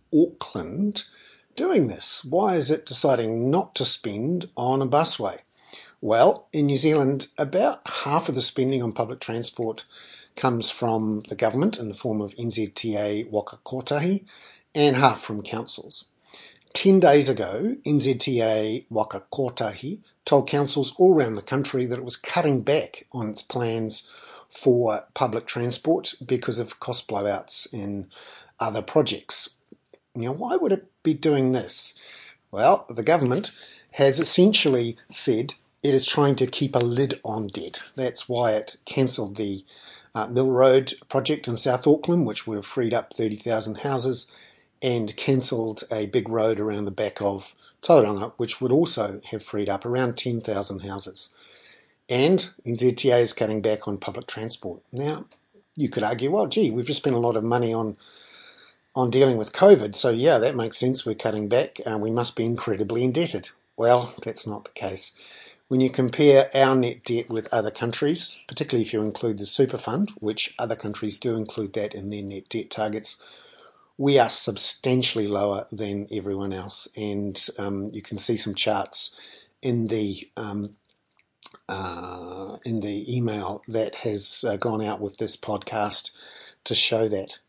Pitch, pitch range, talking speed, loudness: 115 Hz, 105-135 Hz, 160 wpm, -23 LUFS